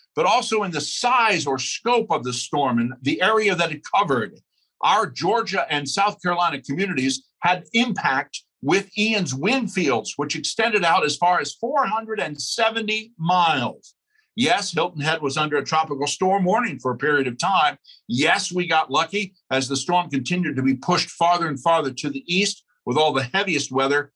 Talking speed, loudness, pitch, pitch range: 180 wpm, -21 LUFS, 170 Hz, 140-200 Hz